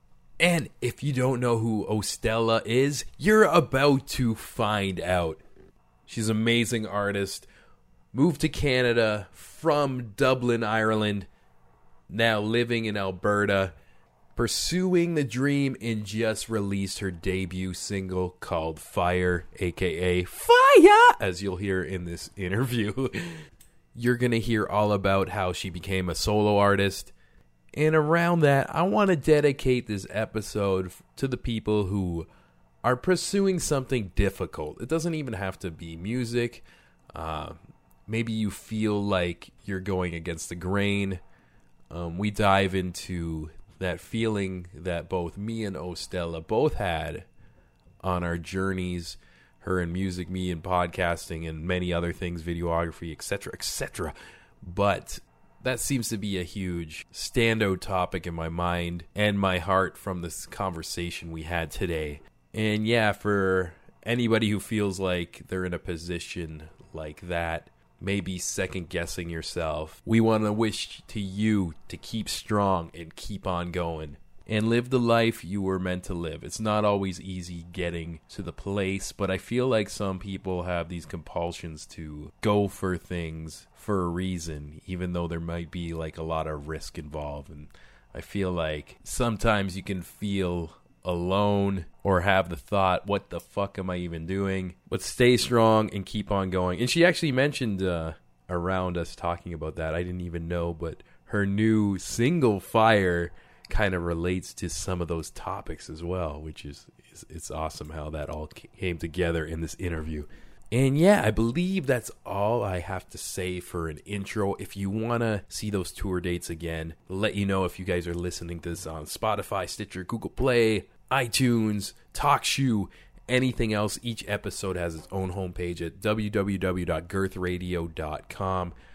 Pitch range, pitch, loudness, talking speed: 85-110 Hz, 95 Hz, -27 LUFS, 155 wpm